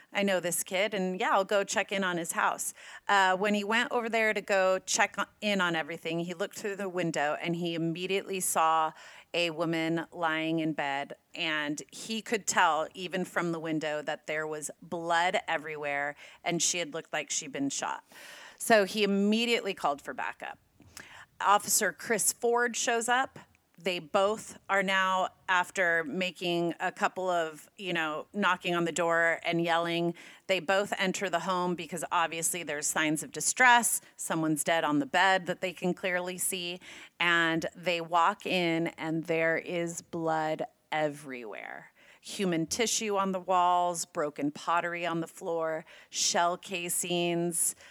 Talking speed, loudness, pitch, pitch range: 165 wpm, -29 LUFS, 175 Hz, 165-195 Hz